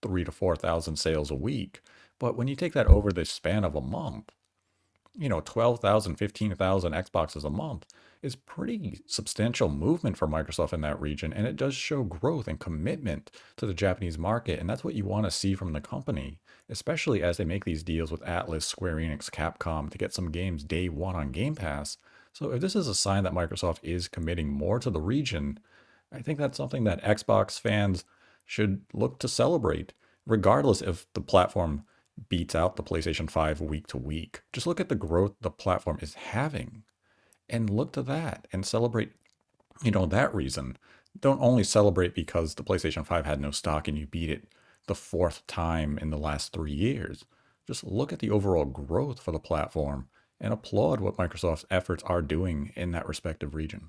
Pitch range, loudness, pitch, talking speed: 80-105 Hz, -30 LUFS, 90 Hz, 190 wpm